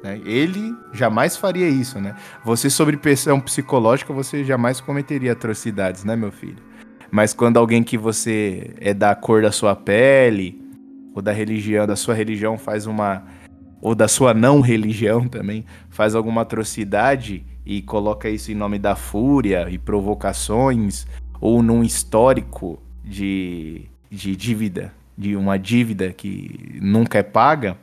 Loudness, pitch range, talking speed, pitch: -19 LUFS, 100-120 Hz, 140 wpm, 110 Hz